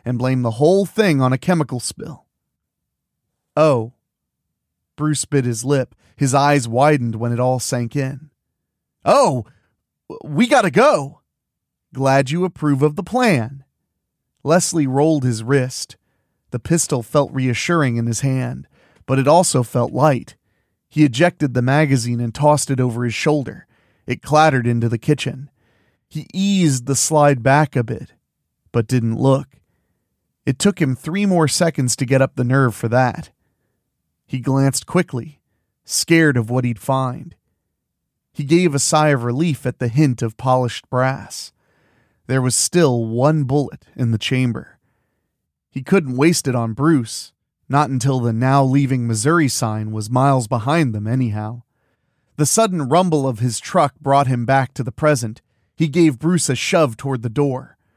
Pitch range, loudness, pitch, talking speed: 120-150 Hz, -18 LUFS, 135 Hz, 160 wpm